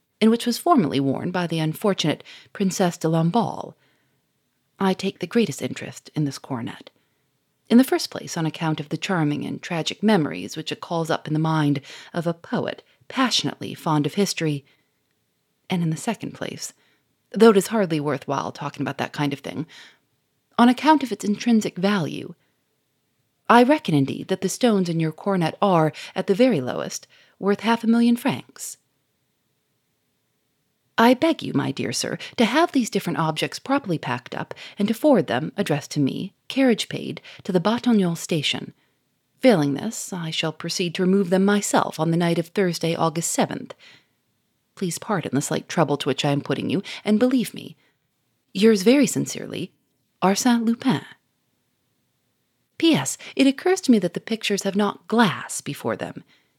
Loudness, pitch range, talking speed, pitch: -22 LUFS, 150-220 Hz, 175 wpm, 180 Hz